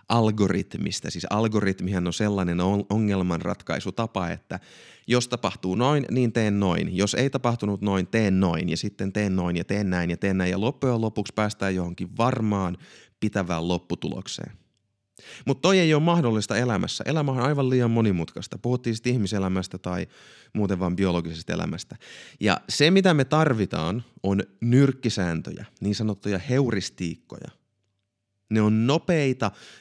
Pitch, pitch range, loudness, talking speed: 105 Hz, 95-120 Hz, -25 LUFS, 140 wpm